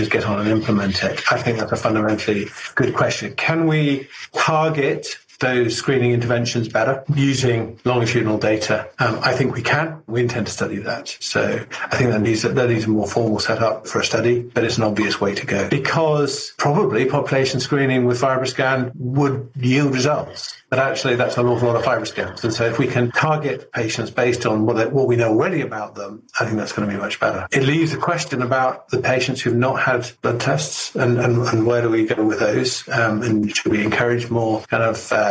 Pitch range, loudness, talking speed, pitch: 110-135 Hz, -19 LUFS, 215 wpm, 120 Hz